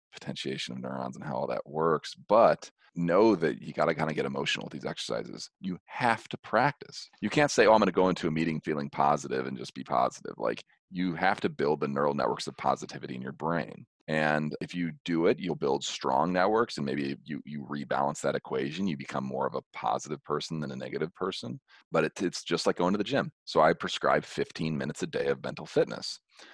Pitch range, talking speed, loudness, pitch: 70-90 Hz, 230 wpm, -30 LUFS, 75 Hz